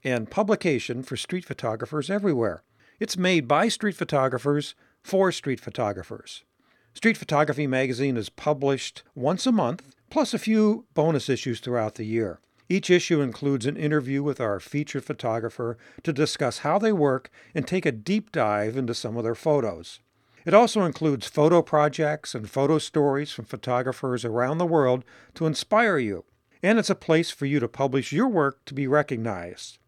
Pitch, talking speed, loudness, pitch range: 145 Hz, 165 wpm, -25 LUFS, 125-165 Hz